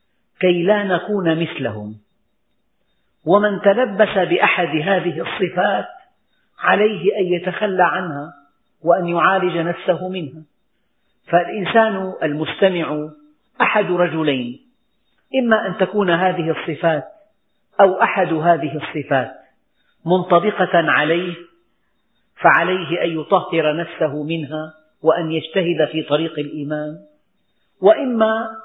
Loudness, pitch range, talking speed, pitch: -18 LUFS, 155-200 Hz, 90 wpm, 175 Hz